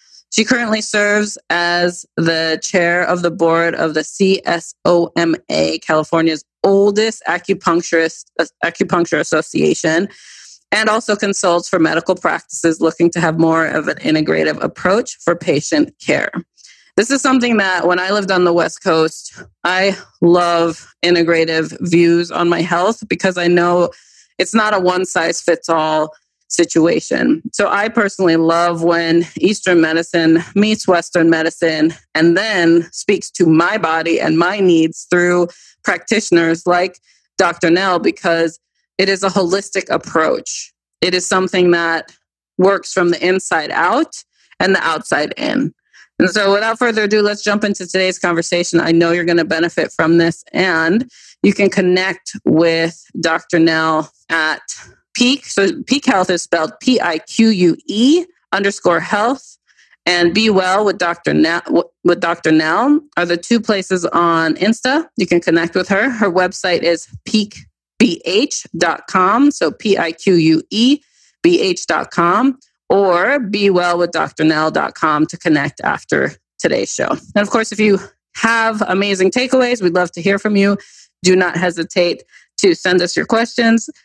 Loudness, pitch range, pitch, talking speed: -15 LUFS, 170-205 Hz, 180 Hz, 145 wpm